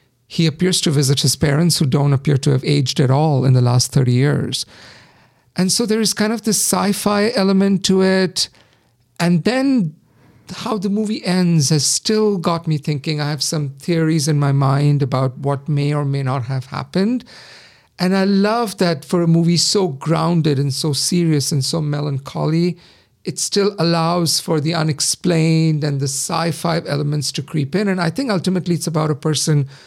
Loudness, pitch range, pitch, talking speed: -17 LUFS, 140-185 Hz, 160 Hz, 190 wpm